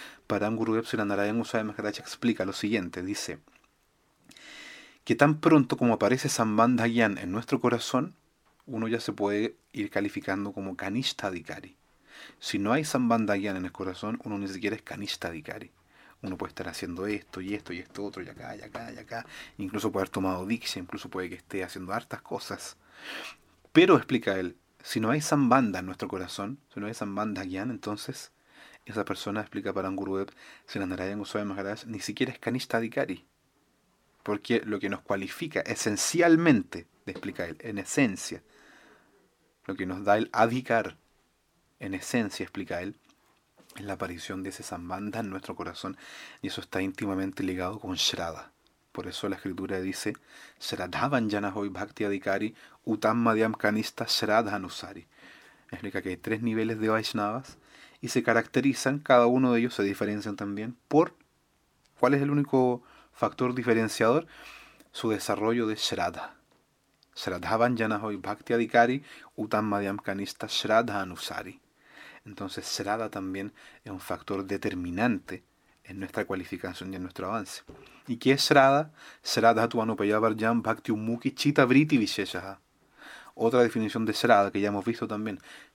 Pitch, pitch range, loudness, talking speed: 105 Hz, 100-115 Hz, -29 LUFS, 150 wpm